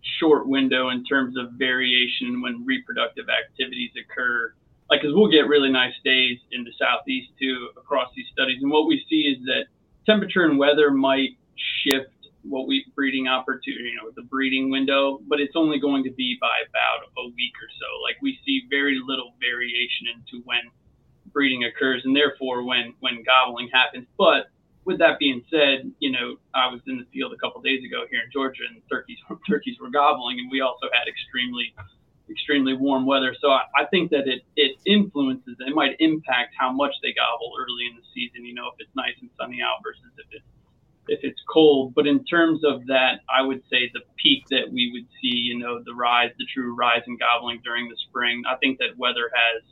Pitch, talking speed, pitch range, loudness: 135 Hz, 210 wpm, 125-155 Hz, -22 LUFS